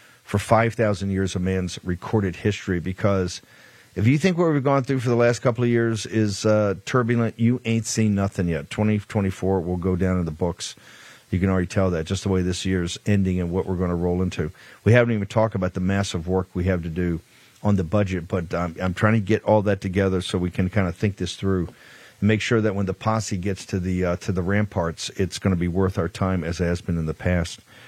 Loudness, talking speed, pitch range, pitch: -23 LUFS, 250 wpm, 90-110 Hz, 95 Hz